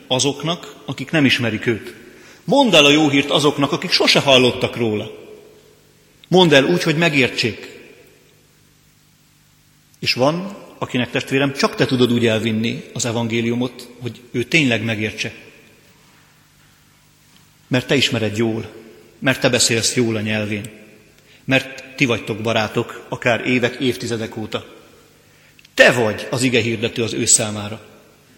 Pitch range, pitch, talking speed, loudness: 115-140 Hz, 125 Hz, 130 wpm, -17 LUFS